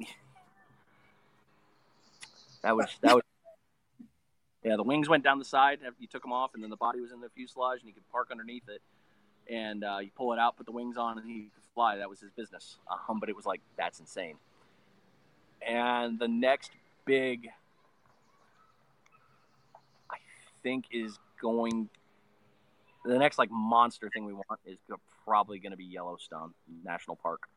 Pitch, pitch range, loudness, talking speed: 115 Hz, 105-125 Hz, -31 LUFS, 170 wpm